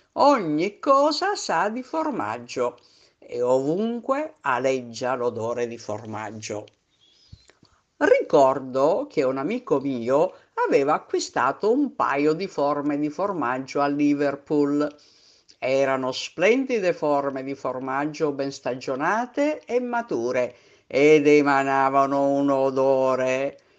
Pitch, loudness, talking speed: 140 Hz, -23 LUFS, 100 wpm